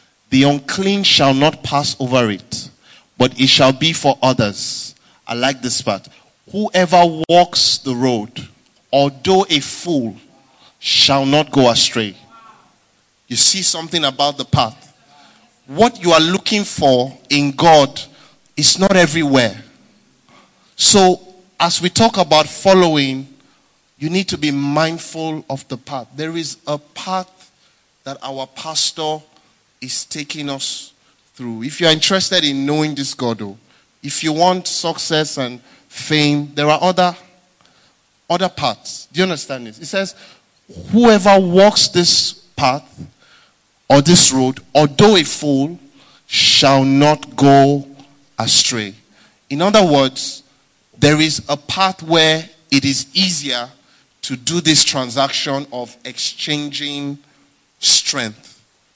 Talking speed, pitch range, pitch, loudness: 130 wpm, 135-175 Hz, 145 Hz, -14 LUFS